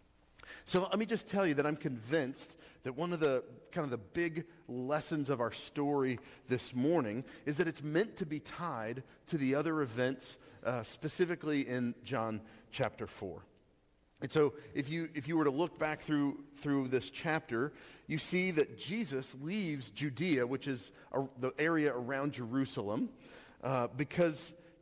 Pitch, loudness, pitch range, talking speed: 145 Hz, -36 LUFS, 130-165 Hz, 165 wpm